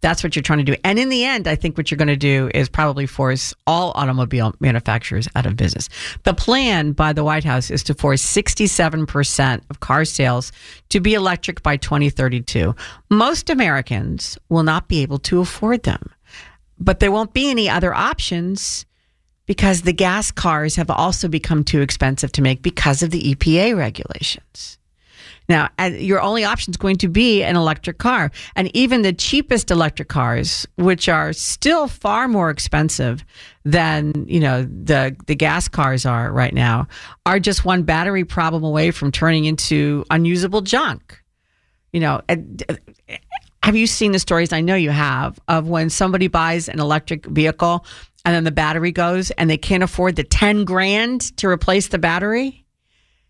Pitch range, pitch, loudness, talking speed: 145-190 Hz, 165 Hz, -18 LUFS, 175 wpm